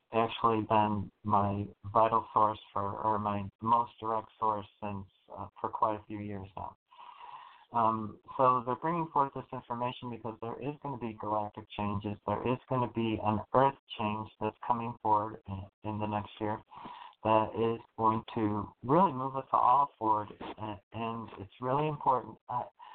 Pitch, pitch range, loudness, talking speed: 110 Hz, 105-125 Hz, -32 LUFS, 170 wpm